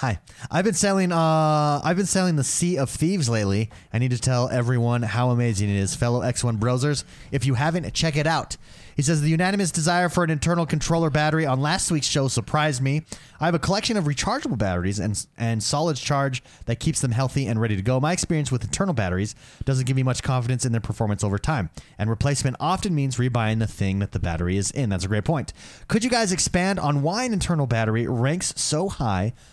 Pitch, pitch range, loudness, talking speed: 135 Hz, 115-160 Hz, -23 LUFS, 225 wpm